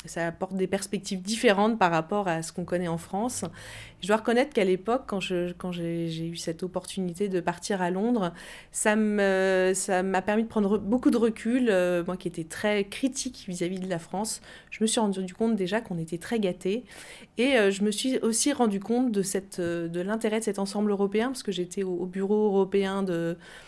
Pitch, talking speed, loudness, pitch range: 195 Hz, 210 wpm, -27 LUFS, 180-220 Hz